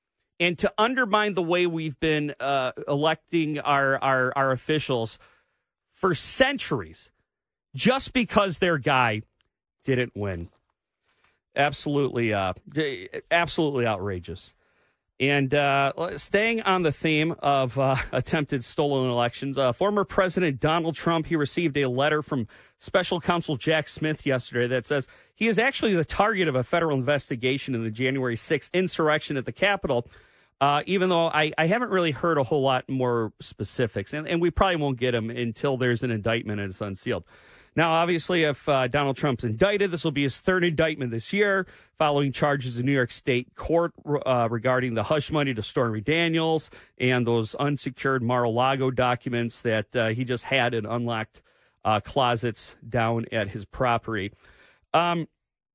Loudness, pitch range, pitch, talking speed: -25 LUFS, 125-165 Hz, 140 Hz, 155 wpm